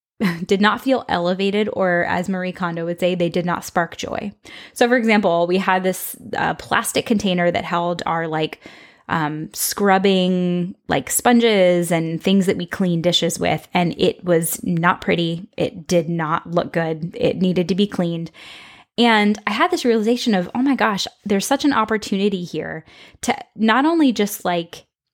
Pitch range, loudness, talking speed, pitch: 175-210 Hz, -19 LUFS, 175 wpm, 185 Hz